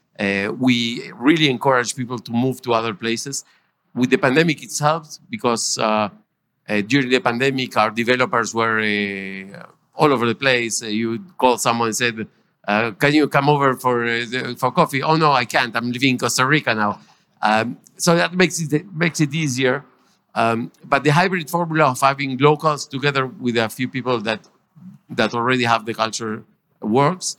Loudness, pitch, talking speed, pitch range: -19 LUFS, 125 Hz, 180 wpm, 115-145 Hz